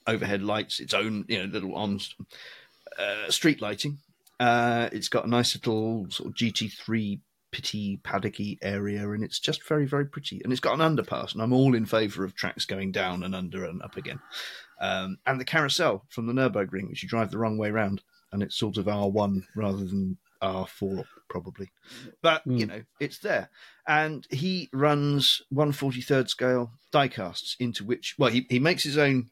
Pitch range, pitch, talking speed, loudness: 100-135 Hz, 110 Hz, 200 wpm, -27 LUFS